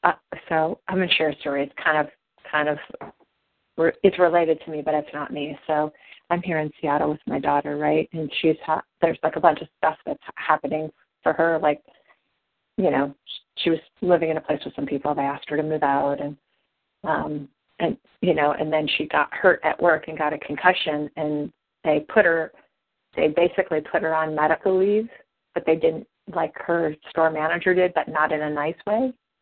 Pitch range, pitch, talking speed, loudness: 150-170 Hz, 155 Hz, 210 wpm, -23 LUFS